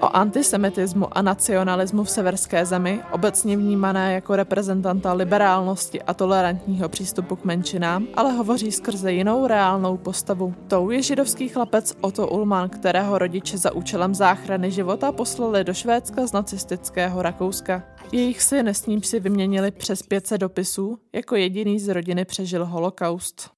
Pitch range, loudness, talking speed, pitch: 185-210 Hz, -22 LUFS, 145 wpm, 195 Hz